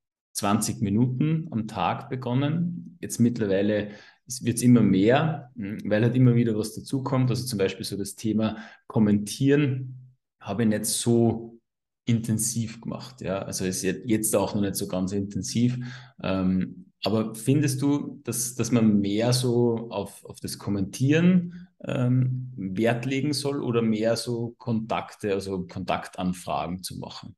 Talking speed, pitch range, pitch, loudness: 140 wpm, 105-125 Hz, 115 Hz, -26 LUFS